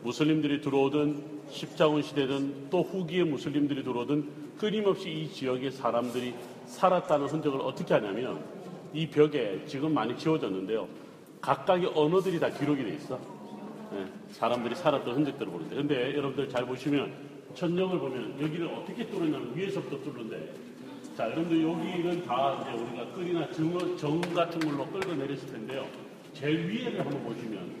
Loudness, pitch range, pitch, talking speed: -31 LUFS, 135-170 Hz, 150 Hz, 365 characters per minute